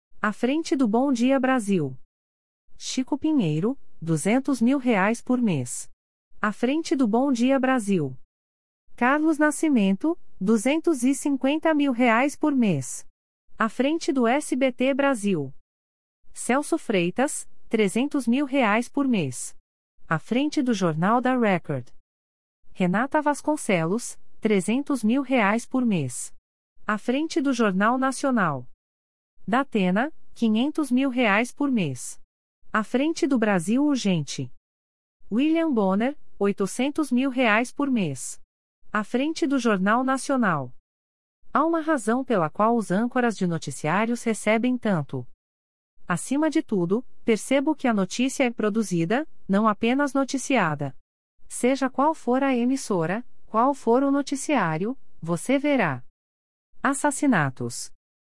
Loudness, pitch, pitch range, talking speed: -24 LUFS, 230 Hz, 160-270 Hz, 120 wpm